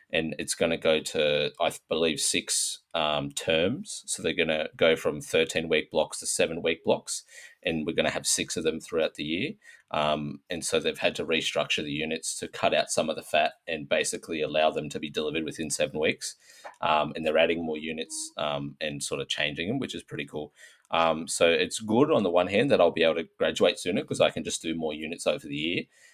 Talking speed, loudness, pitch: 235 wpm, -27 LUFS, 80 Hz